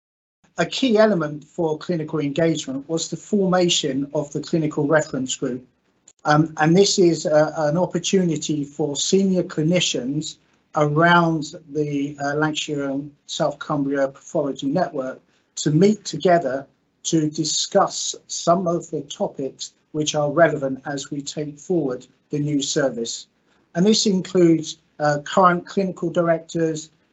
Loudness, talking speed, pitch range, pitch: -21 LUFS, 130 wpm, 145-170 Hz, 155 Hz